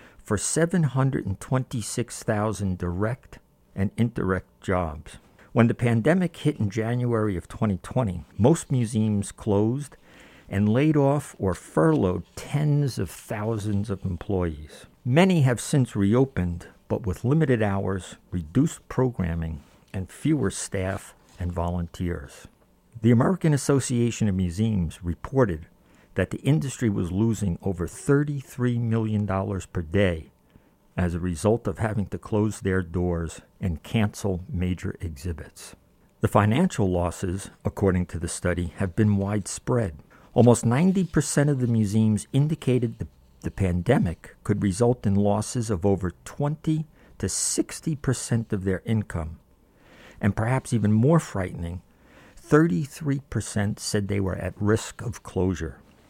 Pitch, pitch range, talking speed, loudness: 105 Hz, 90-125 Hz, 125 wpm, -25 LUFS